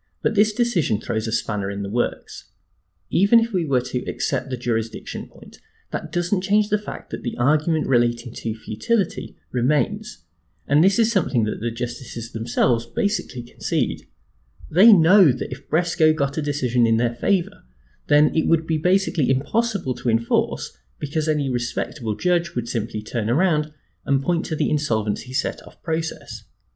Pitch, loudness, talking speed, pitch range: 135 Hz, -22 LUFS, 170 wpm, 115-170 Hz